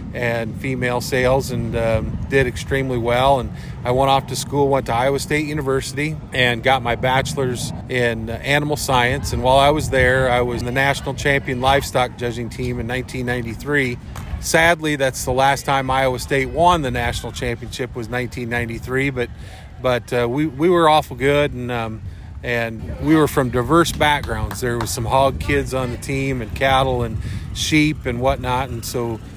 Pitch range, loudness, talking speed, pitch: 120-135 Hz, -19 LUFS, 175 wpm, 125 Hz